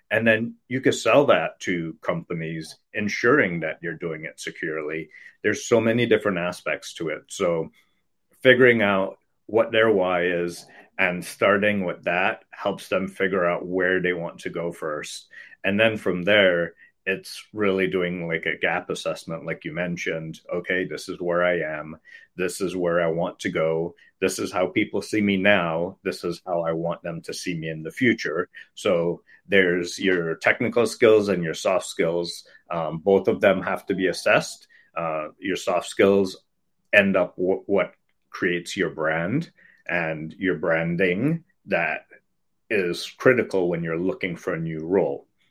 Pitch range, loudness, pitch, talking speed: 85-100 Hz, -23 LUFS, 90 Hz, 170 wpm